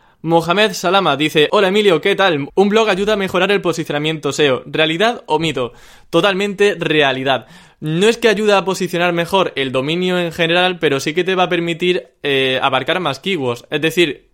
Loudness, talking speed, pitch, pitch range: -15 LUFS, 185 wpm, 175 Hz, 155-195 Hz